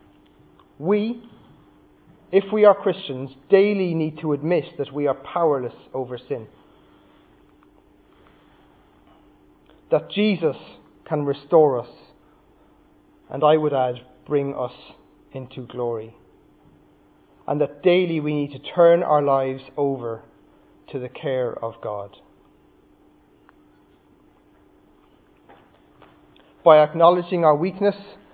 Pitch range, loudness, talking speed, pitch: 135-185 Hz, -21 LUFS, 100 wpm, 150 Hz